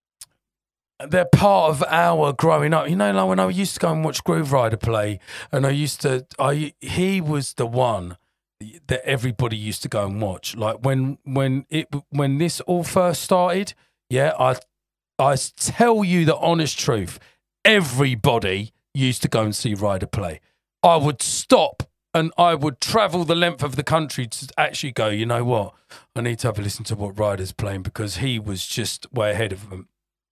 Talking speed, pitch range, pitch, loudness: 190 wpm, 110-160 Hz, 135 Hz, -21 LUFS